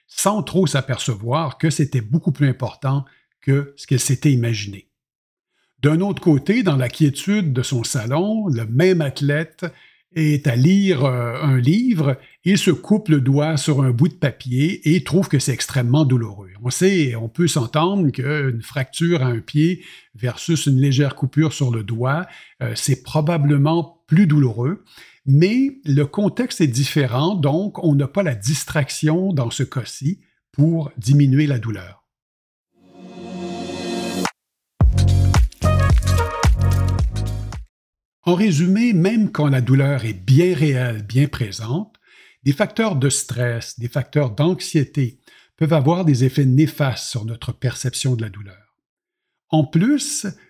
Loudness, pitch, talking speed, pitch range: -19 LUFS, 145 Hz, 140 wpm, 125-165 Hz